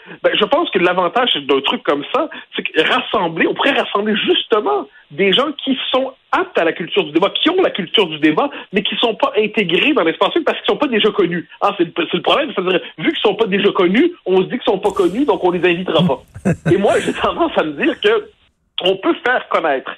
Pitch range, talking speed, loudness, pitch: 180-305 Hz, 250 wpm, -16 LUFS, 220 Hz